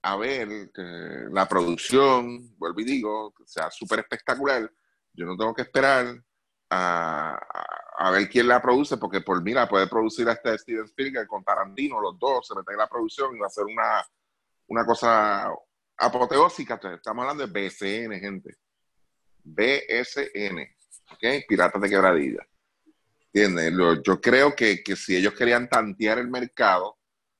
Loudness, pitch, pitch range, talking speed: -24 LUFS, 120 Hz, 105-135 Hz, 155 wpm